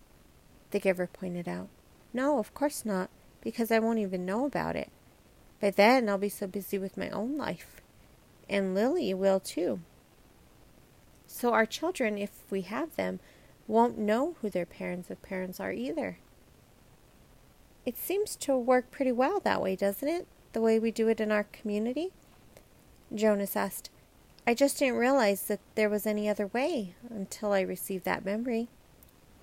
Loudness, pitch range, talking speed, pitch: -30 LUFS, 195-250 Hz, 165 wpm, 215 Hz